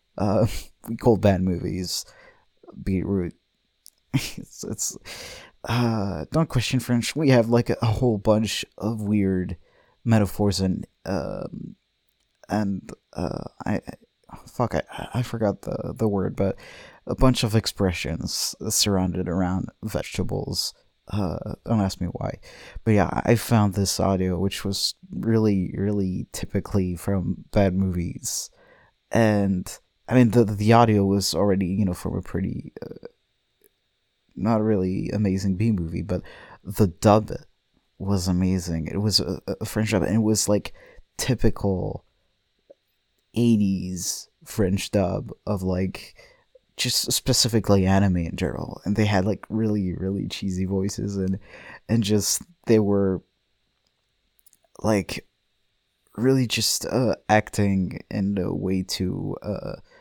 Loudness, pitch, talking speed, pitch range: -24 LUFS, 100 Hz, 130 wpm, 95-110 Hz